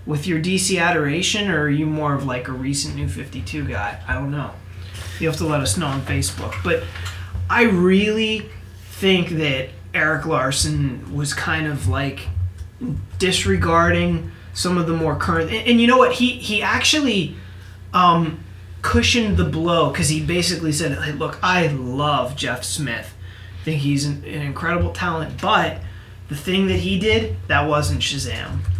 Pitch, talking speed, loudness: 140 Hz, 170 wpm, -20 LUFS